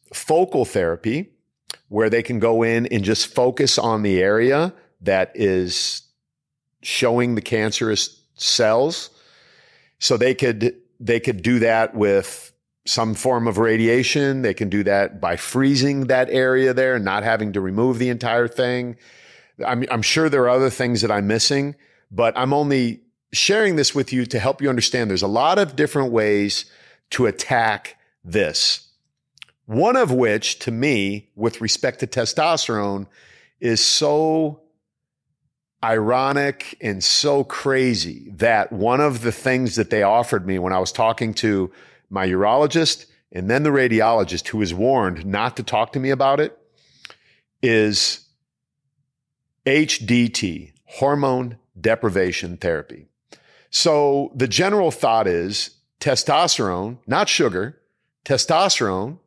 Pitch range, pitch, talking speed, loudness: 110-135 Hz, 120 Hz, 140 wpm, -19 LUFS